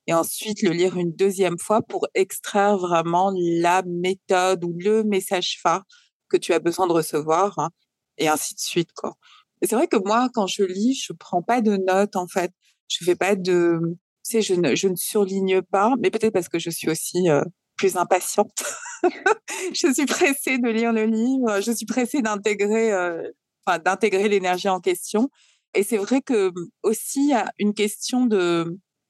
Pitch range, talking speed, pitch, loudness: 180-225 Hz, 190 wpm, 195 Hz, -22 LUFS